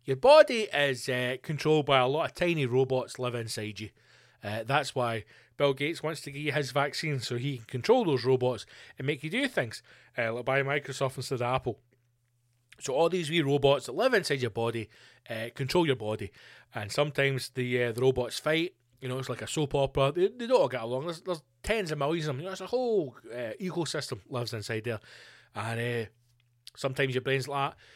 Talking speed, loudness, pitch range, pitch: 215 wpm, -29 LUFS, 120-150 Hz, 130 Hz